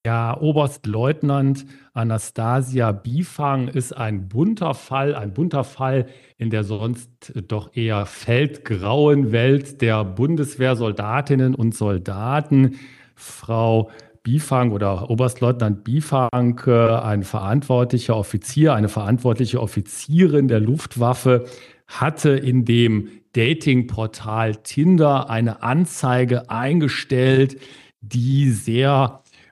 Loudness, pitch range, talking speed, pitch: -20 LUFS, 115-135 Hz, 95 wpm, 125 Hz